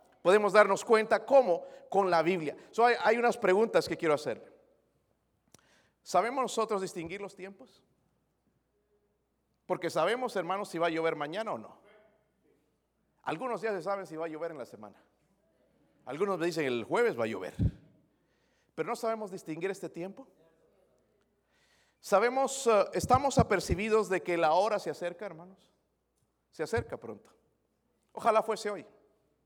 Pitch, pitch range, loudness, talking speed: 205 Hz, 175-230 Hz, -30 LUFS, 145 wpm